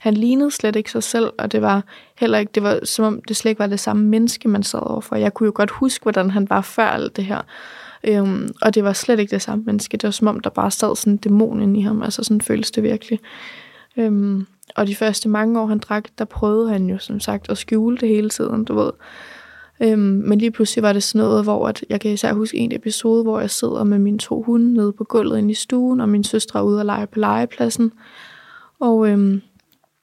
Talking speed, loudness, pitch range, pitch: 250 wpm, -18 LUFS, 205-225 Hz, 215 Hz